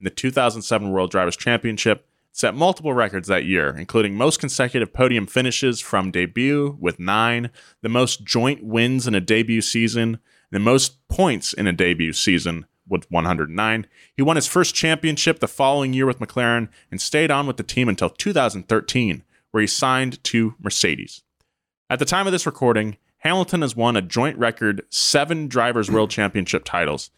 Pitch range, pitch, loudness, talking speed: 105-135 Hz, 120 Hz, -20 LUFS, 170 wpm